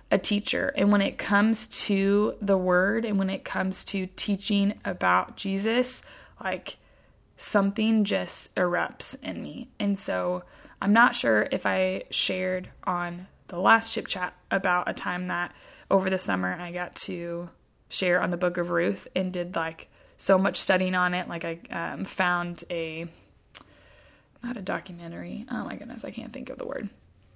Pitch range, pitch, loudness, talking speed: 175-200 Hz, 185 Hz, -26 LUFS, 170 wpm